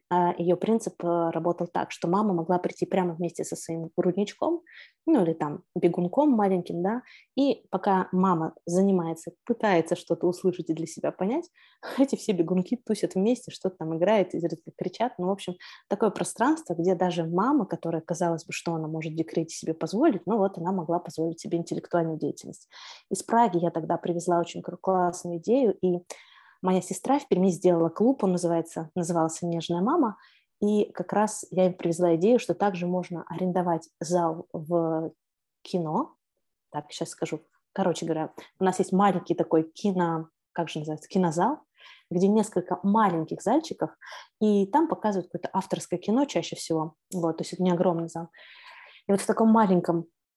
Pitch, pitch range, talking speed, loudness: 180 Hz, 170-200 Hz, 165 wpm, -27 LUFS